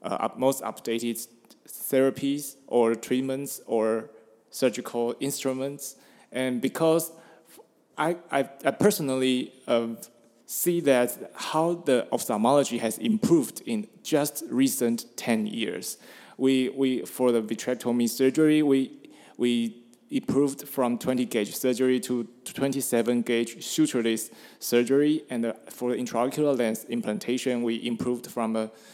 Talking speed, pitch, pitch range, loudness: 120 wpm, 125 Hz, 115-140 Hz, -26 LUFS